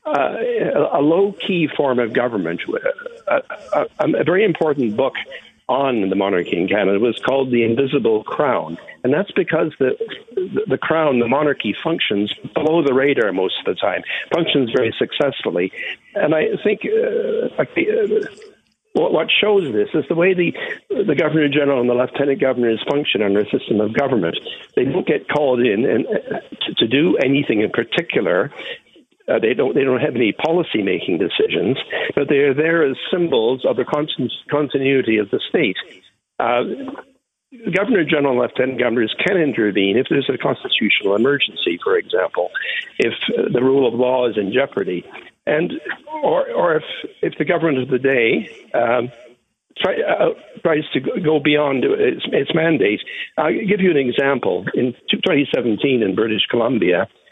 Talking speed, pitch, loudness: 165 wpm, 225 Hz, -18 LUFS